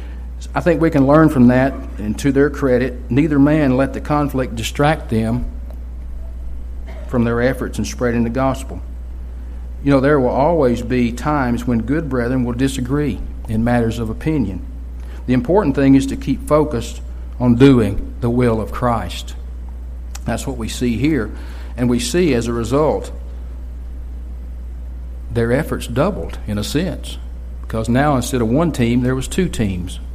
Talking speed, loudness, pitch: 160 wpm, -17 LUFS, 115 Hz